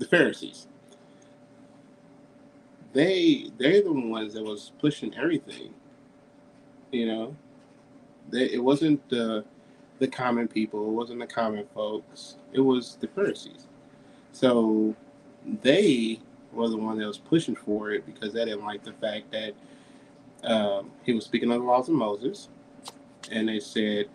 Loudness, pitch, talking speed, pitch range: -27 LUFS, 115 Hz, 140 wpm, 110-130 Hz